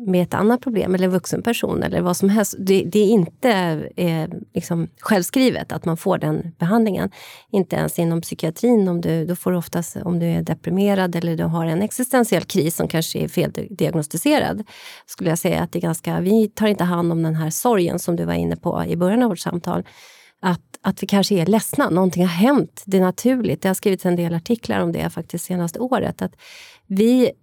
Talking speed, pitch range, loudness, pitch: 215 wpm, 170-215 Hz, -20 LUFS, 185 Hz